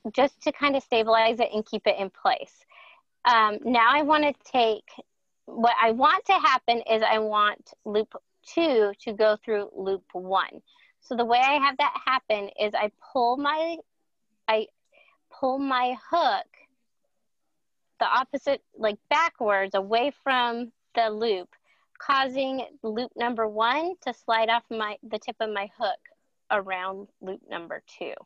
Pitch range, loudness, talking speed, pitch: 215-275 Hz, -25 LUFS, 155 wpm, 235 Hz